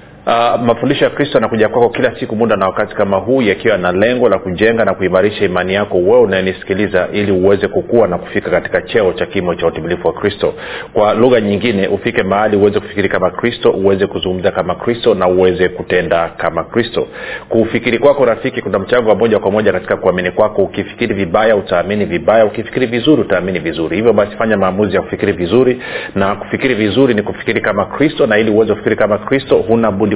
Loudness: -13 LUFS